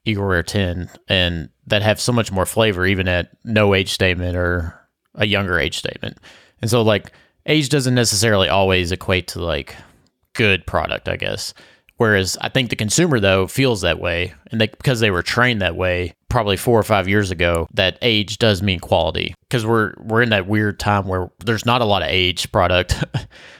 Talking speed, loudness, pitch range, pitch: 195 wpm, -18 LUFS, 90-115 Hz, 100 Hz